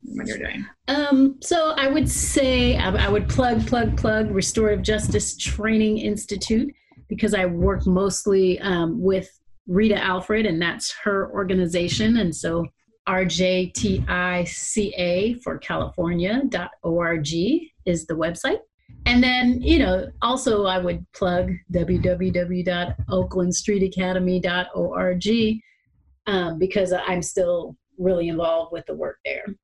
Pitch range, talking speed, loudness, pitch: 180-220 Hz, 115 wpm, -22 LUFS, 190 Hz